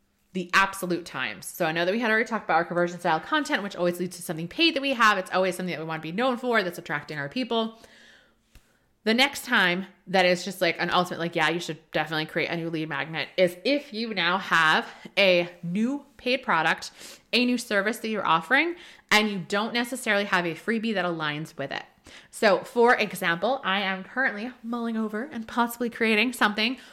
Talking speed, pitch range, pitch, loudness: 215 wpm, 175-235 Hz, 195 Hz, -25 LUFS